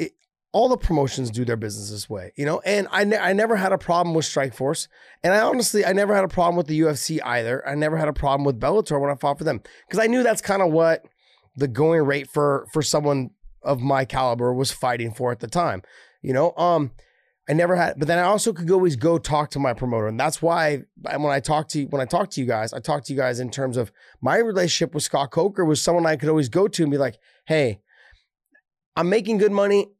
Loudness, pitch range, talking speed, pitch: -22 LUFS, 135-175 Hz, 250 wpm, 155 Hz